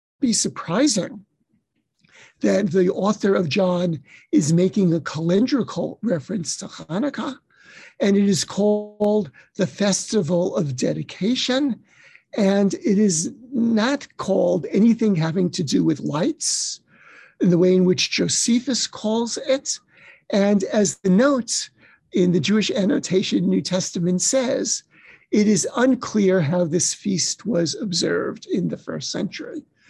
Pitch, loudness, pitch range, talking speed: 200 Hz, -21 LUFS, 180-230 Hz, 125 wpm